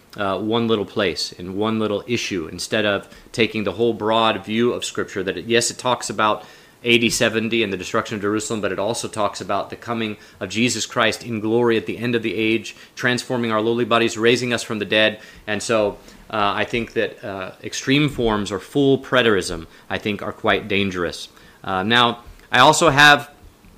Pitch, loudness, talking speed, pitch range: 110 Hz, -20 LUFS, 200 wpm, 105-120 Hz